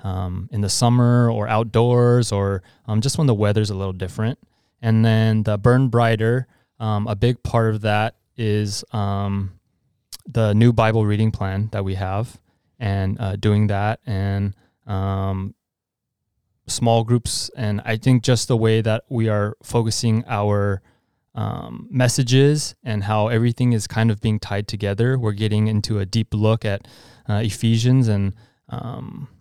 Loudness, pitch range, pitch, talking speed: -20 LUFS, 105-120 Hz, 110 Hz, 155 wpm